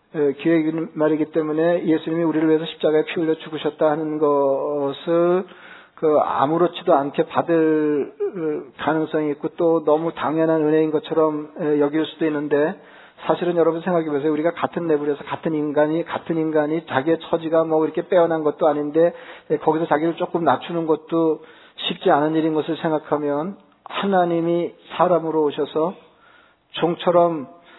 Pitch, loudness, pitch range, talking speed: 160 Hz, -21 LUFS, 150-165 Hz, 340 characters per minute